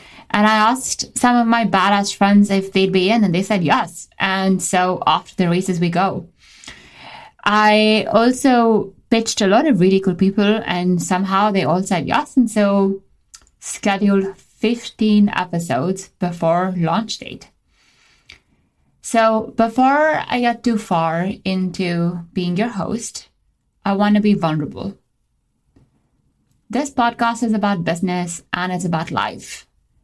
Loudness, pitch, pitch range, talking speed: -17 LUFS, 200 Hz, 180-220 Hz, 140 wpm